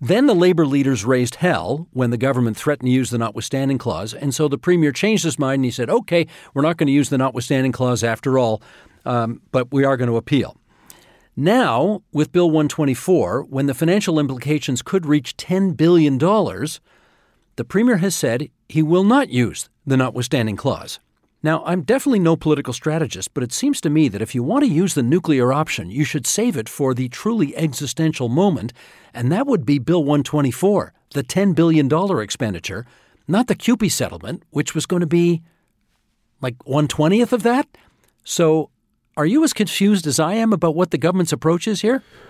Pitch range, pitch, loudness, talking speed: 130-180 Hz, 150 Hz, -19 LUFS, 190 wpm